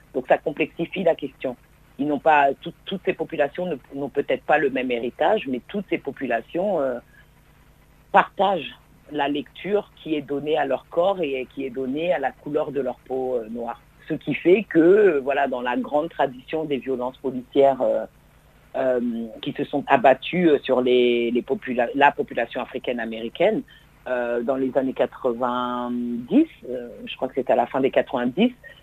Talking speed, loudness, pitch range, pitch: 175 wpm, -23 LUFS, 125-155 Hz, 140 Hz